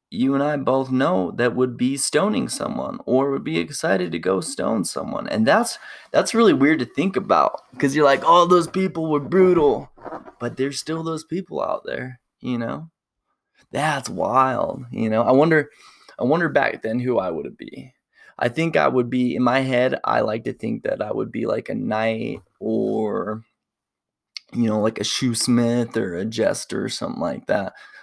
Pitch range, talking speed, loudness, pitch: 120-155 Hz, 195 wpm, -21 LUFS, 130 Hz